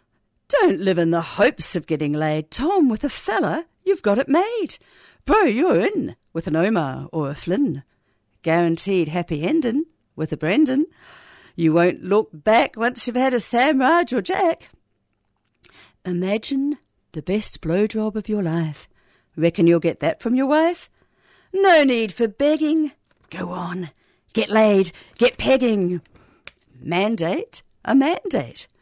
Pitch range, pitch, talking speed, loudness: 165-275 Hz, 205 Hz, 145 wpm, -20 LUFS